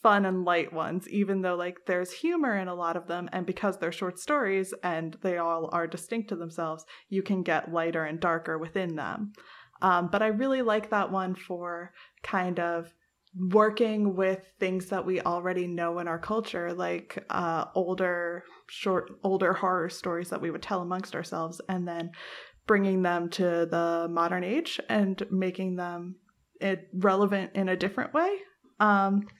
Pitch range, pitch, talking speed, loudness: 175-195 Hz, 185 Hz, 175 wpm, -29 LUFS